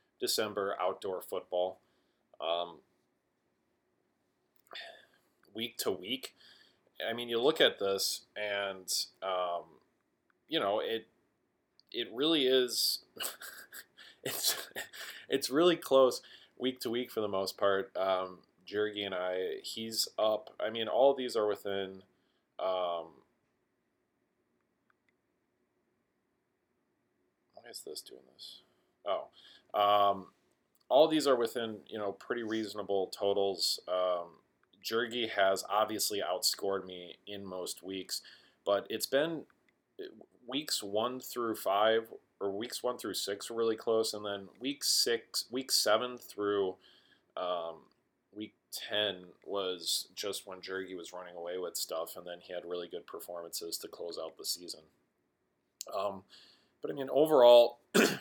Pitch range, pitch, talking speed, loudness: 95-120 Hz, 100 Hz, 125 wpm, -33 LUFS